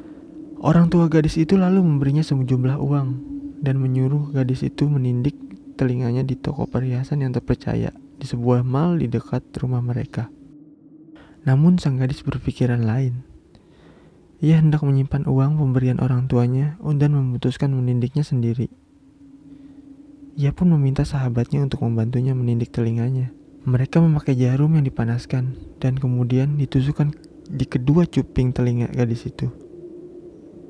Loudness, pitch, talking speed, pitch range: -21 LUFS, 140 Hz, 125 wpm, 125-155 Hz